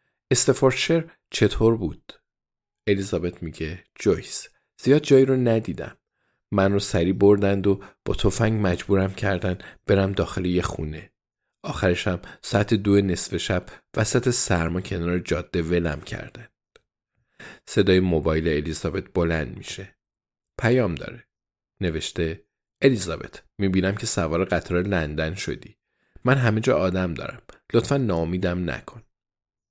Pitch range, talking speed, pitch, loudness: 90-110 Hz, 115 wpm, 95 Hz, -23 LUFS